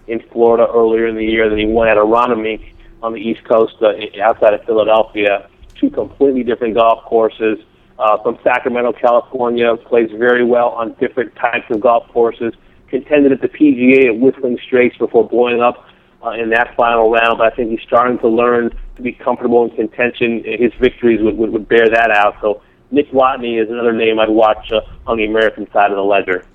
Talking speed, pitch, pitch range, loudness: 200 wpm, 115 Hz, 110-120 Hz, -14 LUFS